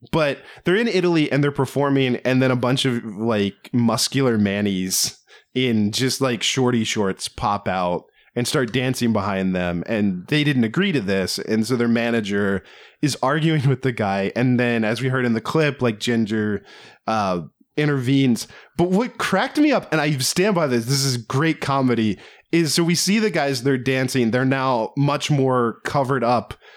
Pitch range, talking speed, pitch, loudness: 110-140 Hz, 185 wpm, 125 Hz, -20 LUFS